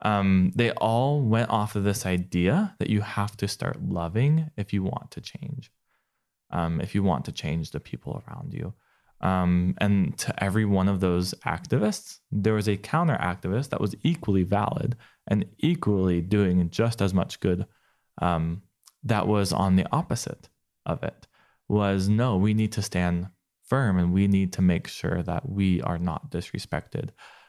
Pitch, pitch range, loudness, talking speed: 100 Hz, 90-110 Hz, -26 LUFS, 170 wpm